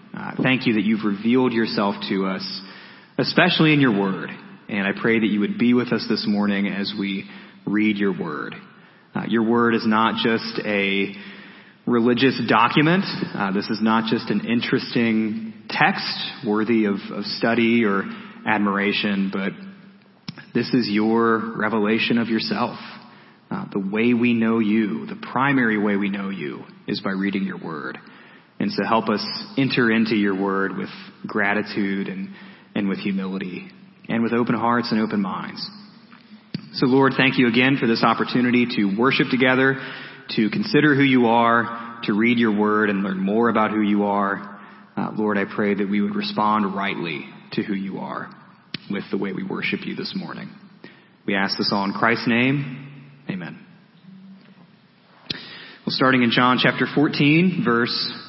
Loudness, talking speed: -21 LUFS, 165 wpm